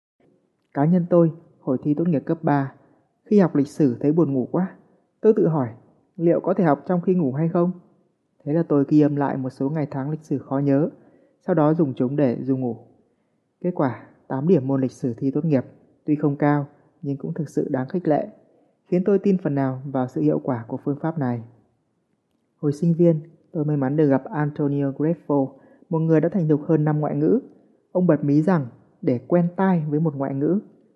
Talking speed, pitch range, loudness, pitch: 220 wpm, 135-170 Hz, -22 LUFS, 150 Hz